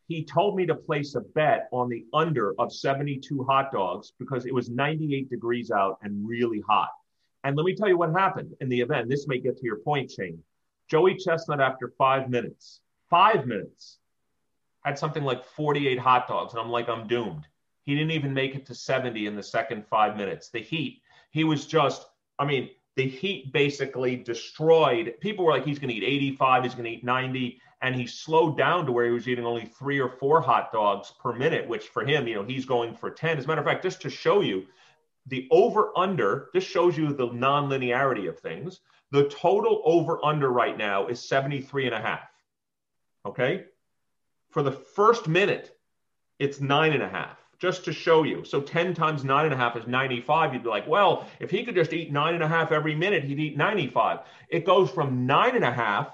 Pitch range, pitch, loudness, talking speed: 125-155 Hz, 140 Hz, -26 LUFS, 210 wpm